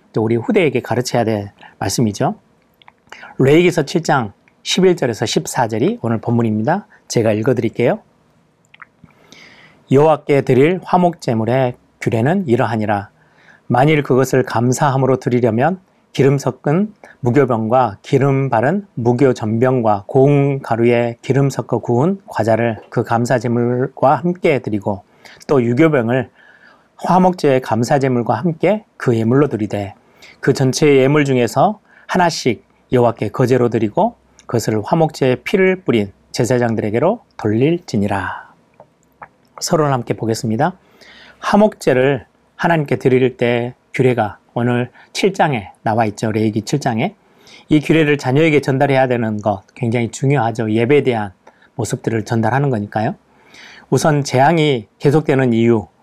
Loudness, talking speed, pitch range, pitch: -16 LUFS, 290 characters per minute, 115-150 Hz, 130 Hz